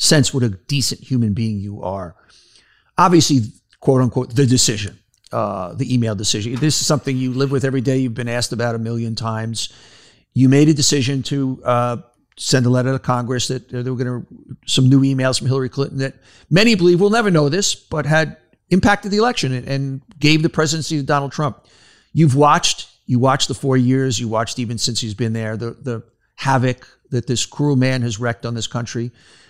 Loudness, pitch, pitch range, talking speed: -18 LUFS, 130 Hz, 120-140 Hz, 200 wpm